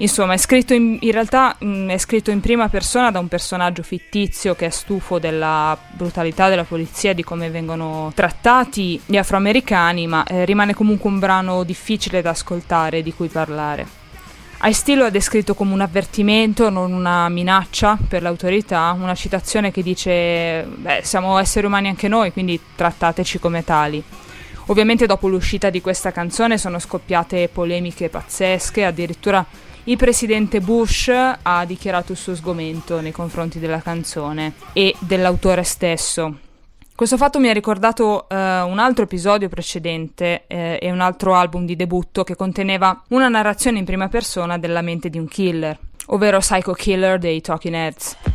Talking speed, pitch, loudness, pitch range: 160 wpm, 185 Hz, -18 LUFS, 170-205 Hz